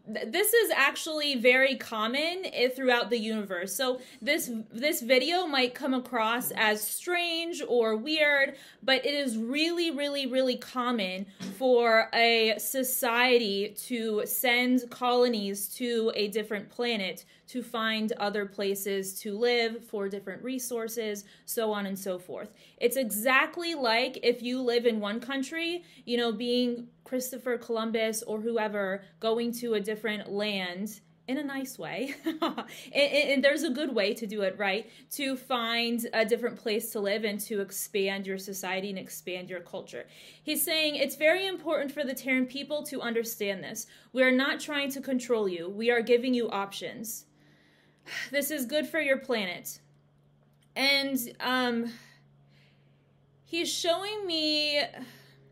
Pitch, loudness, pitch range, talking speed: 235 Hz, -28 LUFS, 210-270 Hz, 150 wpm